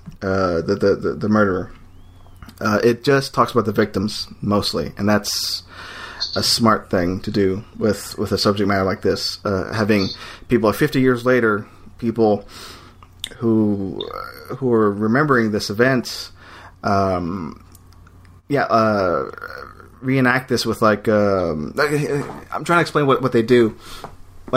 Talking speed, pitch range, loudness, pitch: 140 wpm, 95-120 Hz, -19 LUFS, 105 Hz